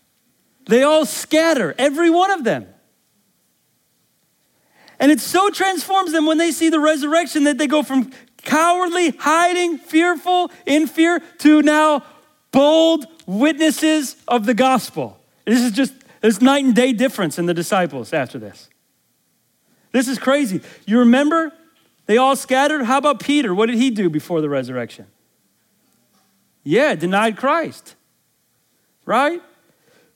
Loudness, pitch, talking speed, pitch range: -17 LUFS, 285 Hz, 135 wpm, 245-320 Hz